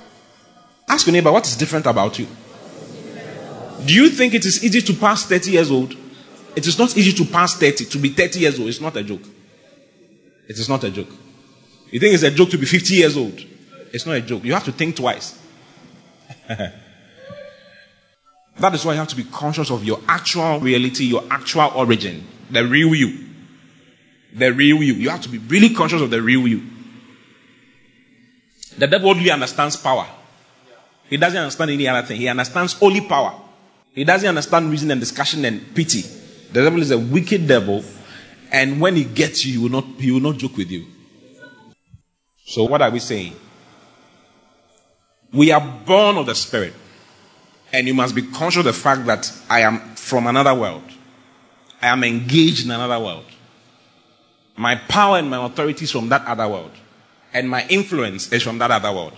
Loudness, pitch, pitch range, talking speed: -17 LUFS, 145 Hz, 125-180 Hz, 190 wpm